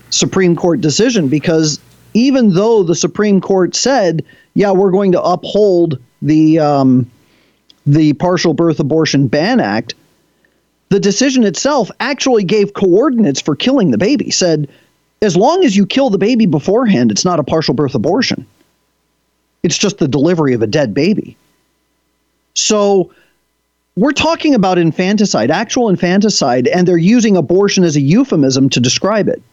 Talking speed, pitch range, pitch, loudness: 150 wpm, 155-210 Hz, 180 Hz, -12 LUFS